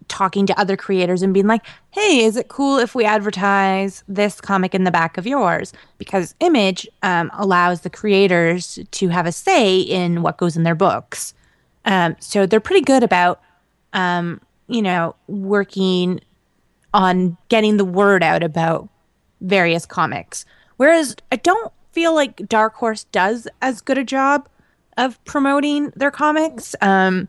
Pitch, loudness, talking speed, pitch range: 200 Hz, -17 LUFS, 160 wpm, 185-245 Hz